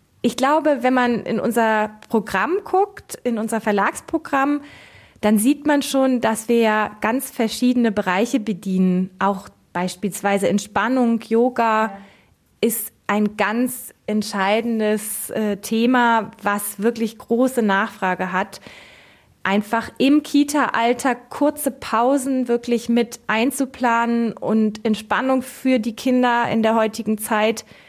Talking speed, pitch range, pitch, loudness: 110 wpm, 210-255 Hz, 230 Hz, -20 LUFS